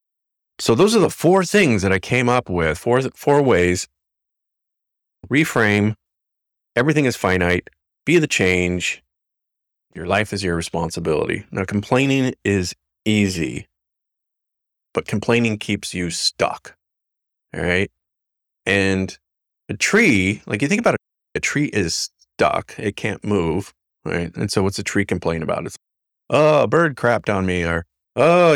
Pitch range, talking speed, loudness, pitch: 90-120 Hz, 145 wpm, -19 LUFS, 100 Hz